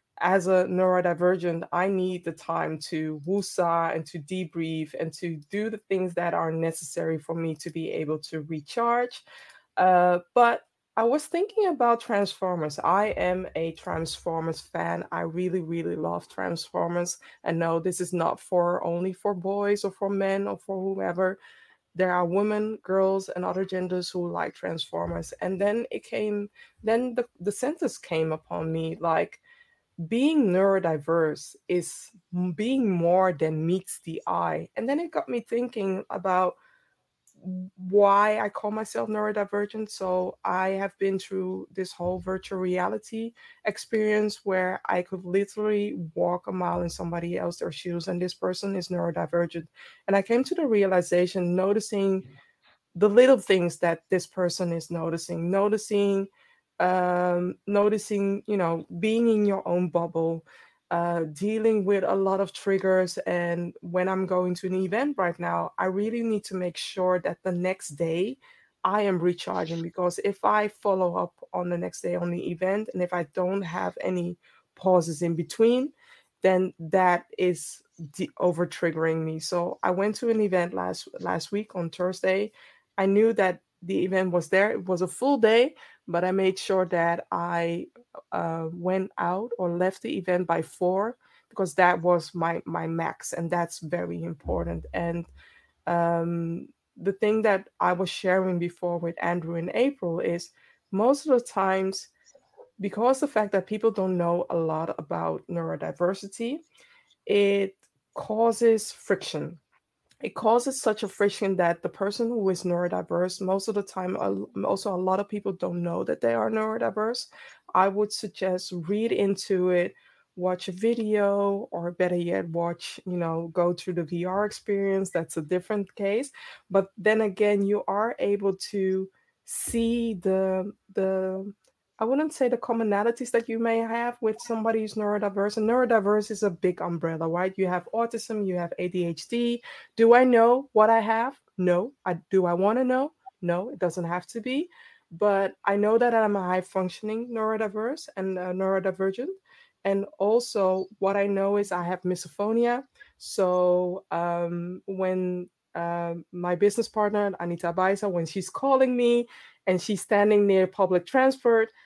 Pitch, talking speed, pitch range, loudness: 190 Hz, 160 wpm, 175-215 Hz, -26 LUFS